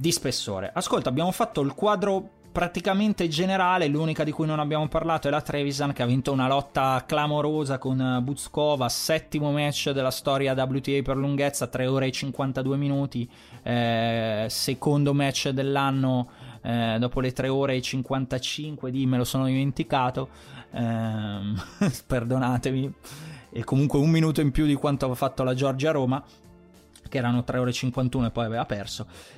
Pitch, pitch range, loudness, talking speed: 135 Hz, 125-150 Hz, -26 LUFS, 165 wpm